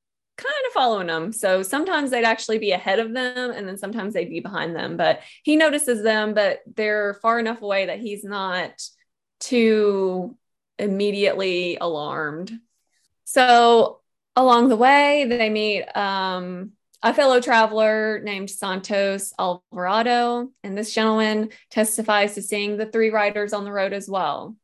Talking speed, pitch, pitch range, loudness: 150 wpm, 215 Hz, 200-240 Hz, -21 LUFS